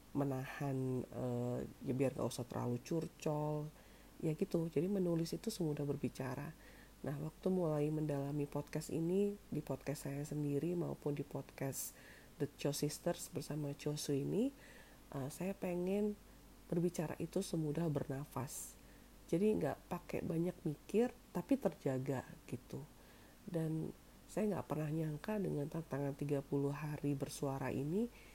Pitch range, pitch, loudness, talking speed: 140-175 Hz, 150 Hz, -41 LUFS, 130 wpm